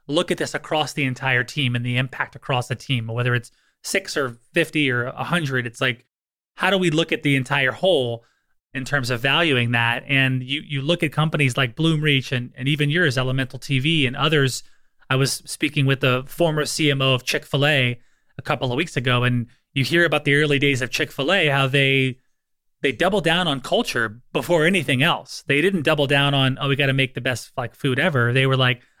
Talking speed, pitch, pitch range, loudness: 215 wpm, 135 Hz, 125-150 Hz, -20 LUFS